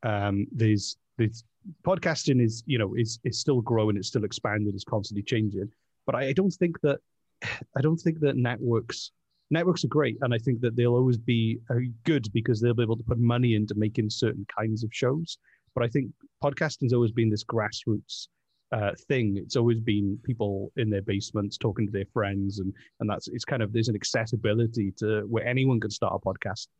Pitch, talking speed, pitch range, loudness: 115 Hz, 200 wpm, 105-130 Hz, -28 LUFS